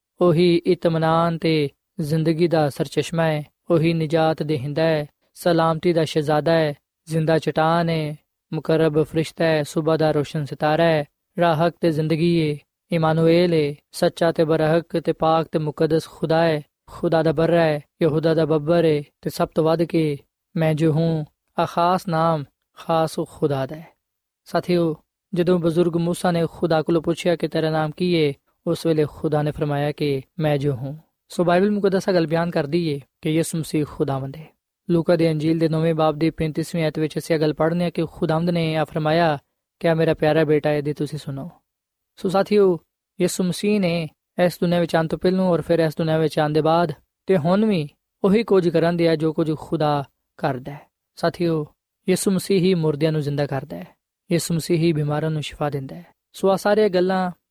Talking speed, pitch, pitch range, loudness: 175 wpm, 165 Hz, 155-170 Hz, -21 LUFS